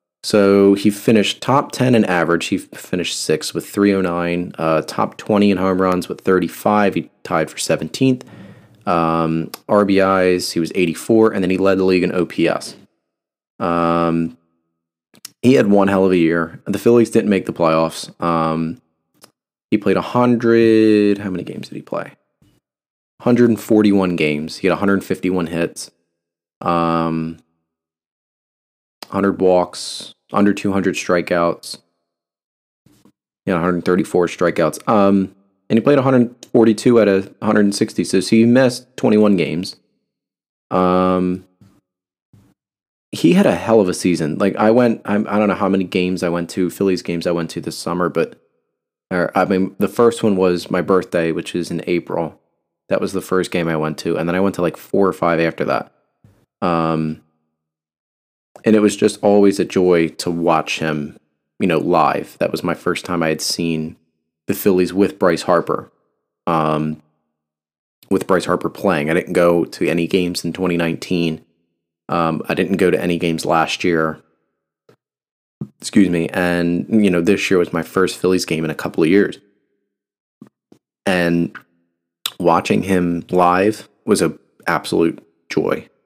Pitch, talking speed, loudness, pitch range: 90 Hz, 160 wpm, -17 LUFS, 80-100 Hz